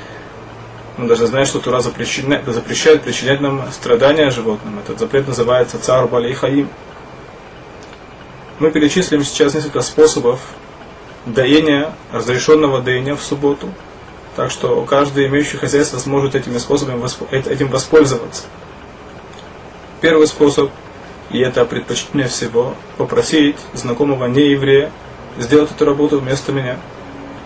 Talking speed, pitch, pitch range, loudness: 110 wpm, 140 Hz, 130-150 Hz, -15 LUFS